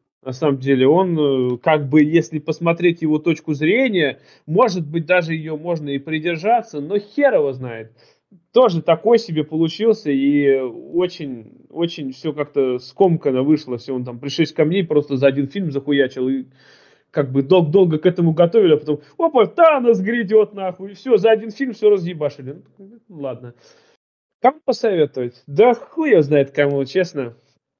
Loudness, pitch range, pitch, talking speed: -18 LUFS, 140-190 Hz, 155 Hz, 160 wpm